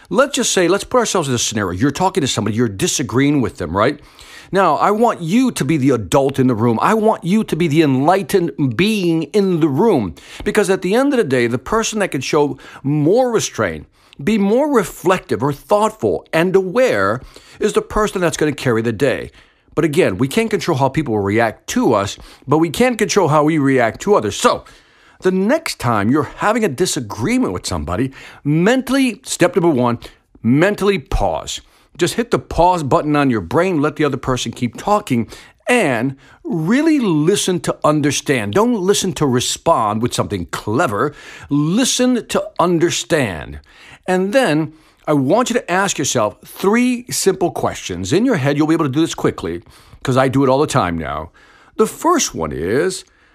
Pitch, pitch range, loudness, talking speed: 165 Hz, 135-210 Hz, -16 LUFS, 190 wpm